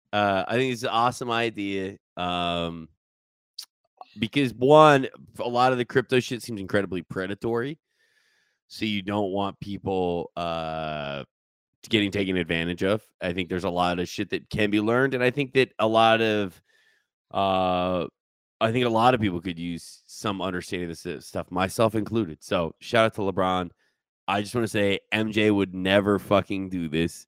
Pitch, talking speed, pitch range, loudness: 100 Hz, 175 wpm, 90-115 Hz, -25 LUFS